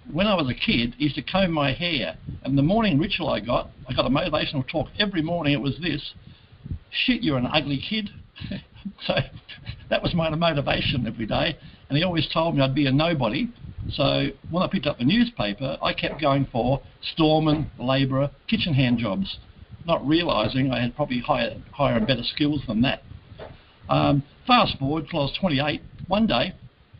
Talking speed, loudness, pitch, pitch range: 190 wpm, -24 LUFS, 145 Hz, 130-165 Hz